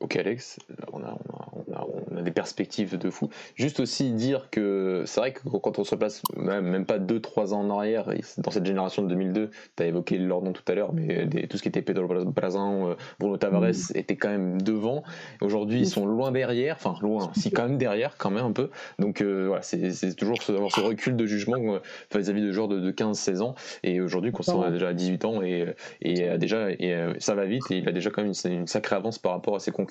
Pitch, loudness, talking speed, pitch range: 100 Hz, -28 LUFS, 255 wpm, 90-110 Hz